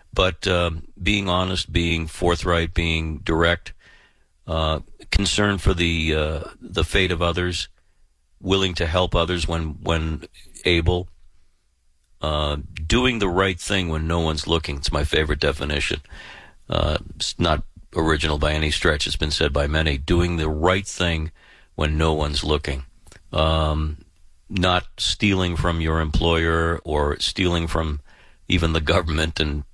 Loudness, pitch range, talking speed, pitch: -22 LUFS, 75-90 Hz, 140 wpm, 80 Hz